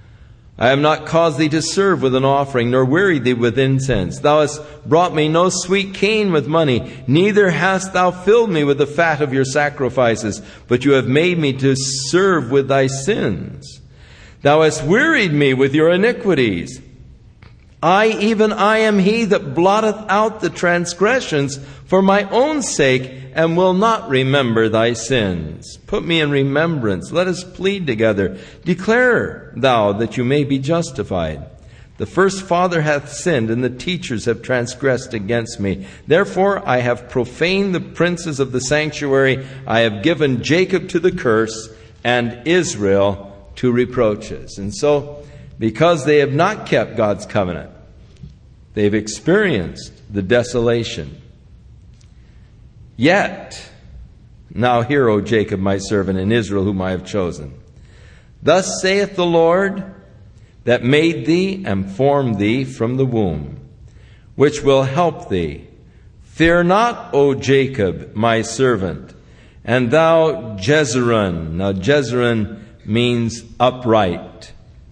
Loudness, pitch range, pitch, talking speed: -16 LUFS, 115-170 Hz, 135 Hz, 140 wpm